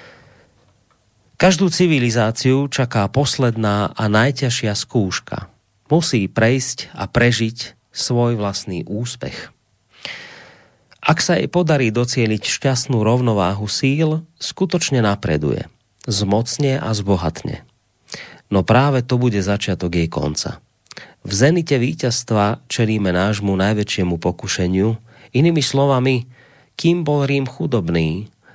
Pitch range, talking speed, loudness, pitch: 100-135 Hz, 100 wpm, -18 LUFS, 120 Hz